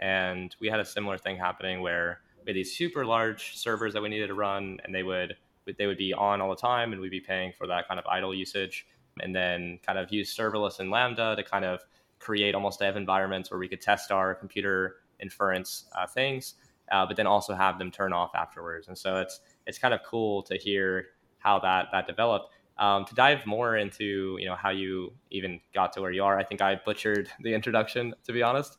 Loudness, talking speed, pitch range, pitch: -29 LUFS, 225 wpm, 95-105 Hz, 100 Hz